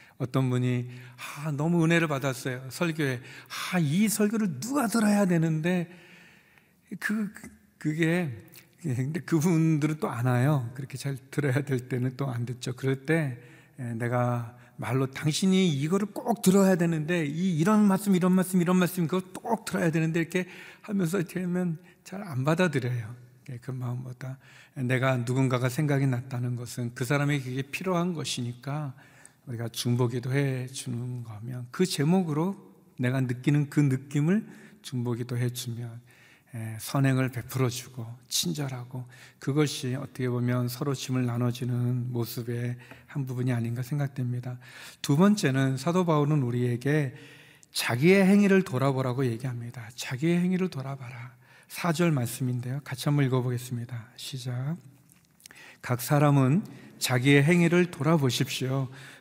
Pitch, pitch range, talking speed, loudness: 135 Hz, 125-170 Hz, 300 characters per minute, -27 LUFS